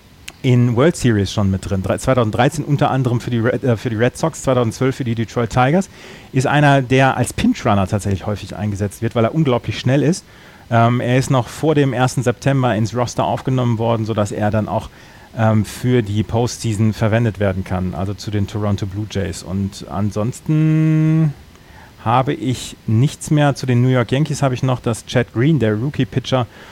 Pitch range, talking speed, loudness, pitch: 105-130 Hz, 195 wpm, -18 LUFS, 120 Hz